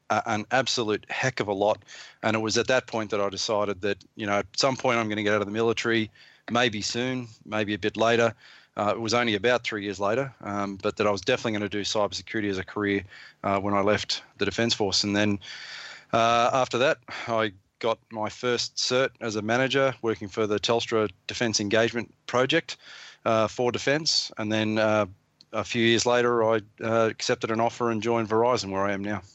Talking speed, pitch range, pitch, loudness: 215 wpm, 105-120 Hz, 110 Hz, -26 LUFS